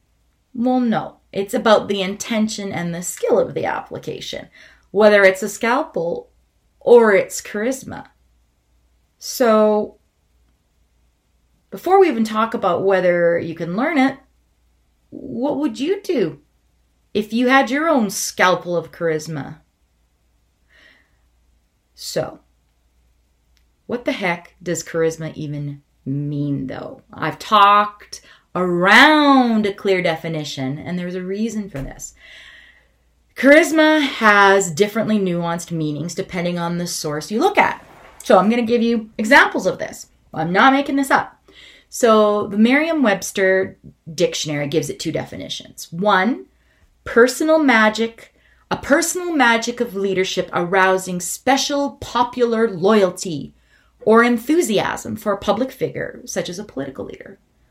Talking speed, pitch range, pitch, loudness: 125 wpm, 160-240 Hz, 200 Hz, -17 LUFS